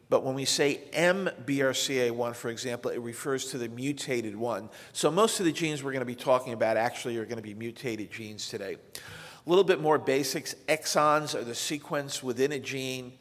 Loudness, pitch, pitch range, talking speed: -29 LUFS, 135 Hz, 120-150 Hz, 200 wpm